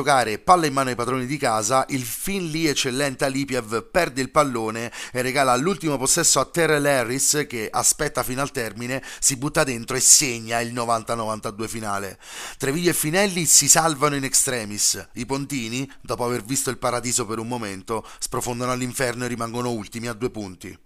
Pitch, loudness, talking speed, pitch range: 130 Hz, -21 LUFS, 175 wpm, 115-140 Hz